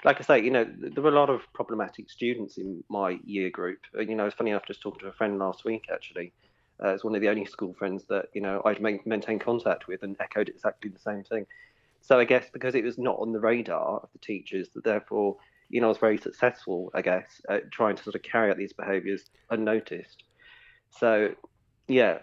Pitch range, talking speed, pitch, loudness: 100-115 Hz, 235 wpm, 105 Hz, -28 LUFS